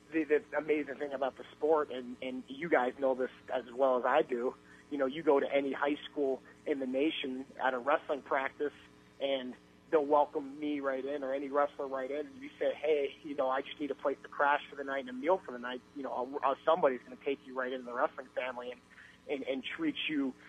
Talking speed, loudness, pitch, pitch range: 245 wpm, -34 LUFS, 135 Hz, 130-150 Hz